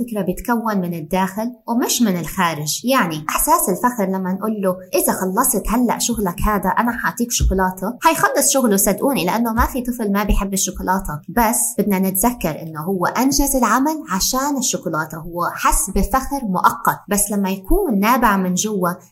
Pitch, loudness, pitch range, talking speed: 205 Hz, -18 LUFS, 185-240 Hz, 155 wpm